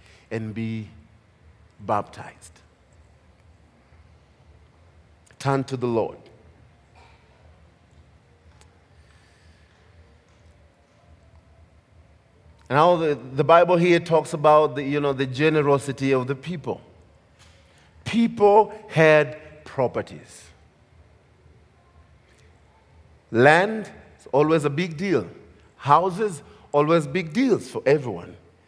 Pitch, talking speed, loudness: 115 Hz, 75 wpm, -21 LUFS